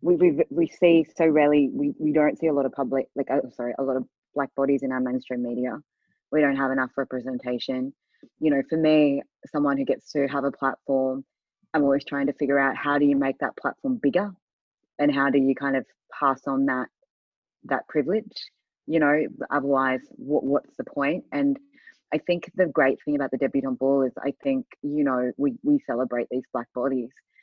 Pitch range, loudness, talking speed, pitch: 135-155 Hz, -25 LUFS, 205 wpm, 140 Hz